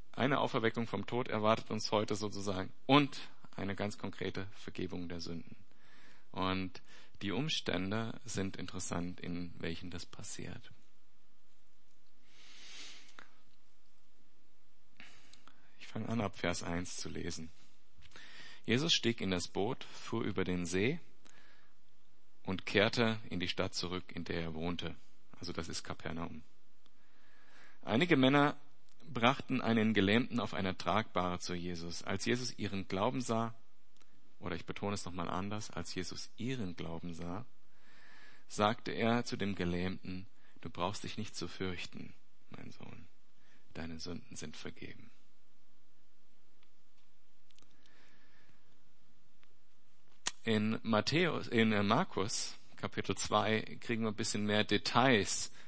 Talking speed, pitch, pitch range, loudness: 120 wpm, 100 Hz, 90-115 Hz, -36 LUFS